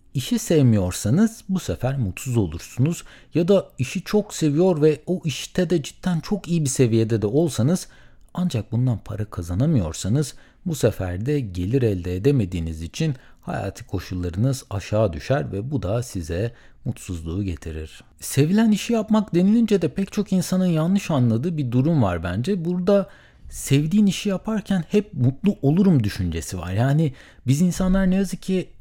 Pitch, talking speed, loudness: 140 Hz, 150 wpm, -22 LUFS